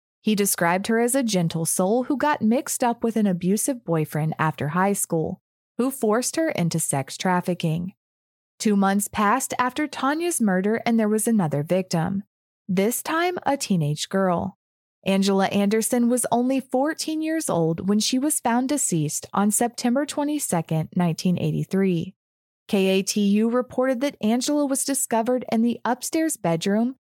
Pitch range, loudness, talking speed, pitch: 185-255 Hz, -23 LUFS, 145 wpm, 215 Hz